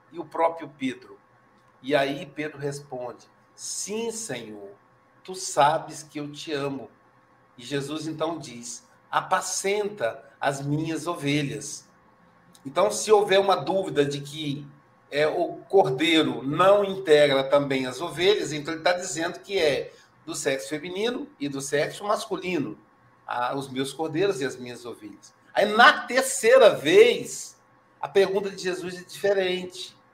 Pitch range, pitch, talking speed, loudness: 140-195 Hz, 160 Hz, 140 wpm, -24 LUFS